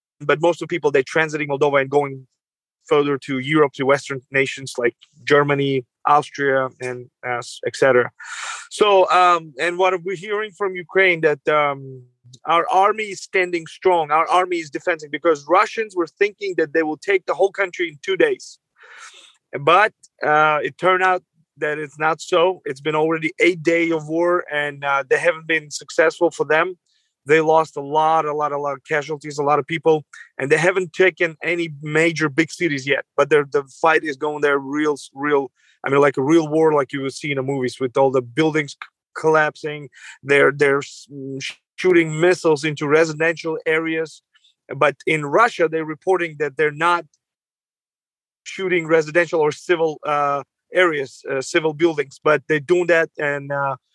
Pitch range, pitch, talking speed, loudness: 145-175 Hz, 155 Hz, 180 wpm, -19 LUFS